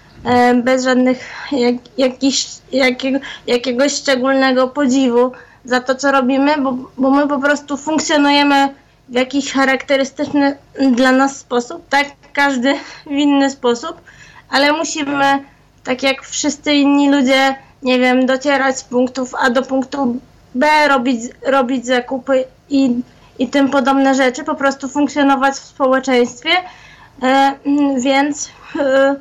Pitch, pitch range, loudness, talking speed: 270 Hz, 260-280 Hz, -15 LUFS, 125 wpm